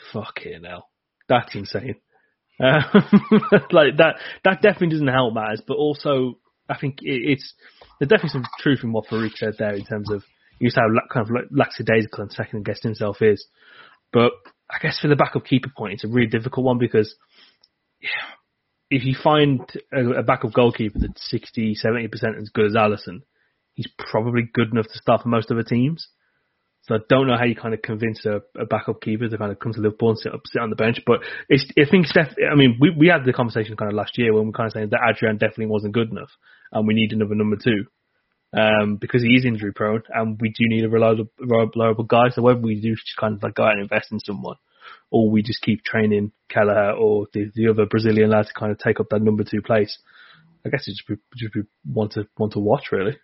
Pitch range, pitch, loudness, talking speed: 110-125 Hz, 115 Hz, -20 LUFS, 225 wpm